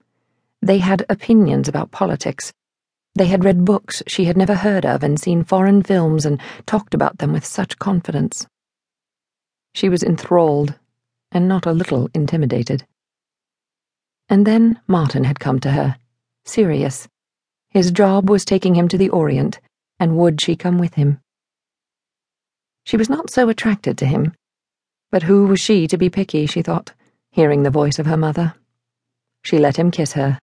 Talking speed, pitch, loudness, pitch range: 160 wpm, 175 Hz, -17 LUFS, 145-195 Hz